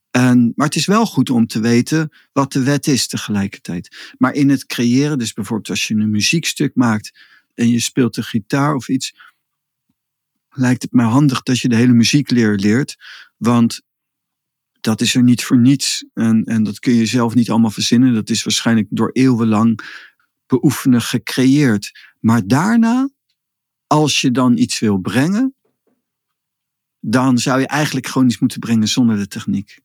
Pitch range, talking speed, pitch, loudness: 115-140 Hz, 170 wpm, 125 Hz, -15 LUFS